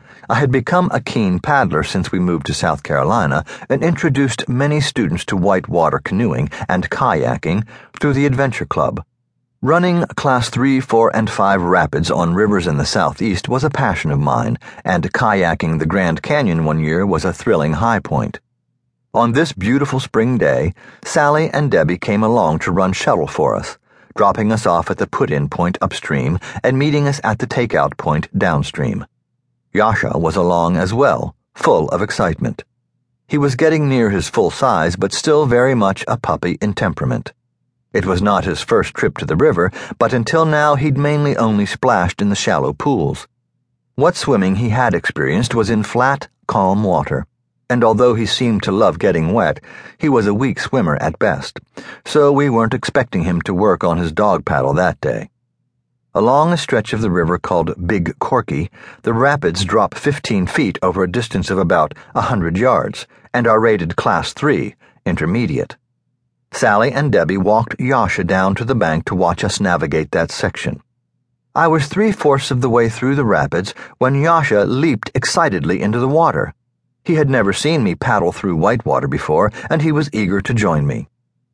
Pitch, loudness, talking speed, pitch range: 125 Hz, -16 LUFS, 180 wpm, 100-140 Hz